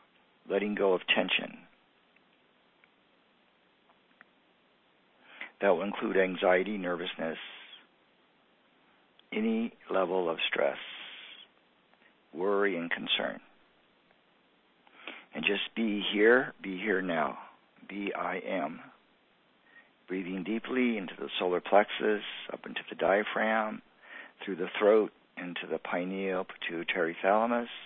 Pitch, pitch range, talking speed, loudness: 100 Hz, 95-110 Hz, 95 wpm, -30 LUFS